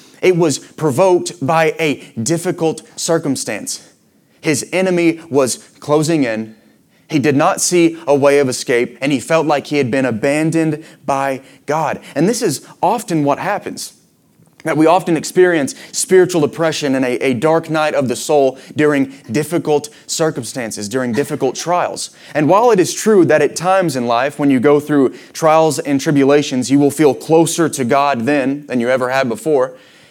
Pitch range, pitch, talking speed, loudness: 135-160 Hz, 150 Hz, 165 wpm, -15 LUFS